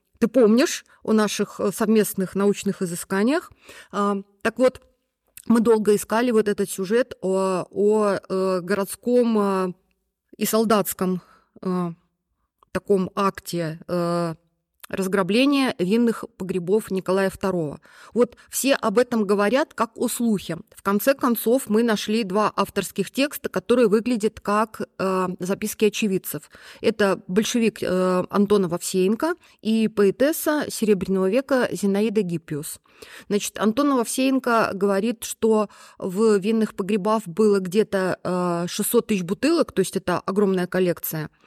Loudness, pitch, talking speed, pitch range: -22 LUFS, 205 Hz, 115 wpm, 190-225 Hz